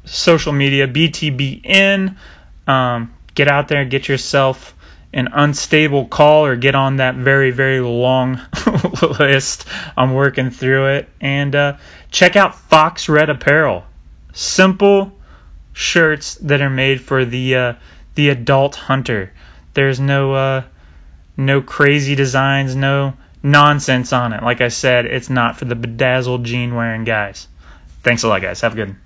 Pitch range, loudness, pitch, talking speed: 120-145 Hz, -14 LUFS, 135 Hz, 150 wpm